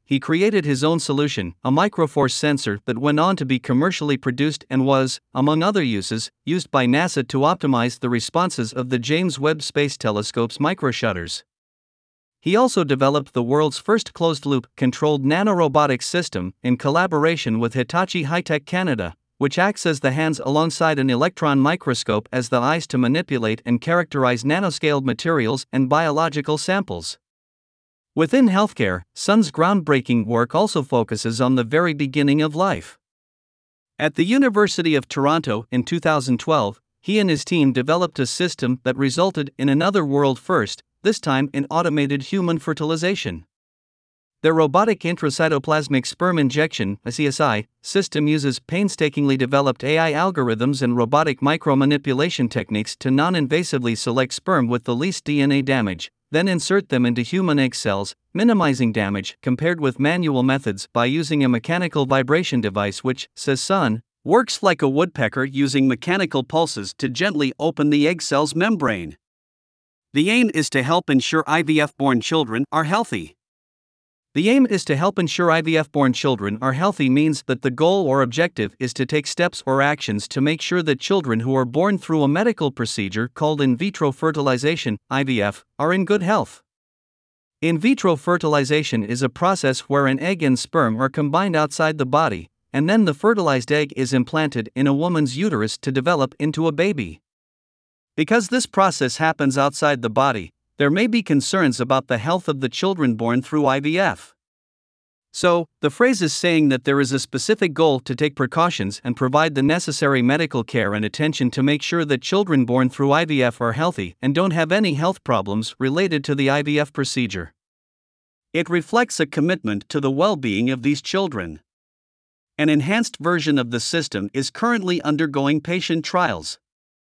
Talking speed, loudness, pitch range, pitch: 160 wpm, -20 LUFS, 125-165 Hz, 145 Hz